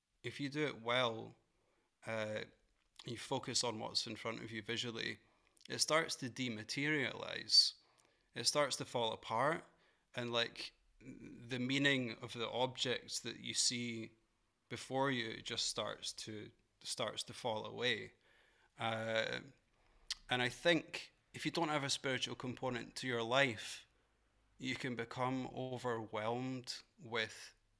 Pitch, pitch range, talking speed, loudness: 120 Hz, 115-130 Hz, 135 wpm, -39 LUFS